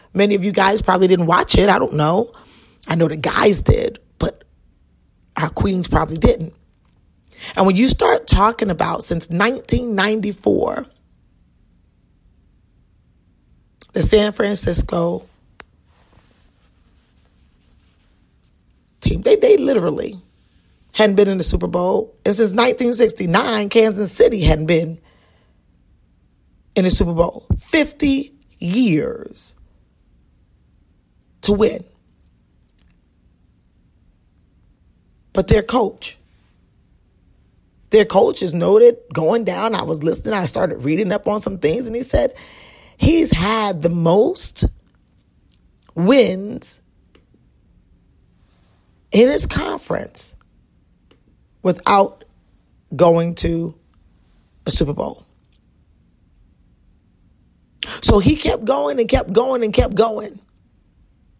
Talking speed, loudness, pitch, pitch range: 100 wpm, -17 LUFS, 200 Hz, 170-225 Hz